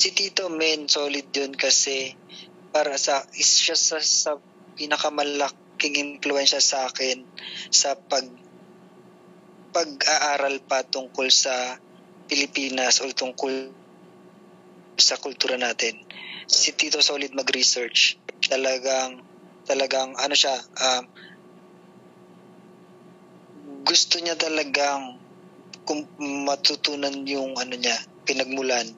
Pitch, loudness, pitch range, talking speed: 140 Hz, -22 LUFS, 130-150 Hz, 95 wpm